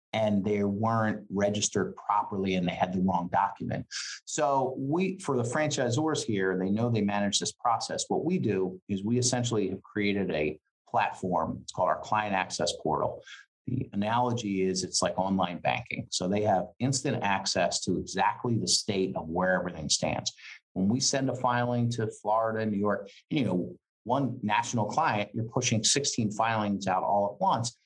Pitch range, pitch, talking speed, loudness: 95-120 Hz, 105 Hz, 175 wpm, -29 LUFS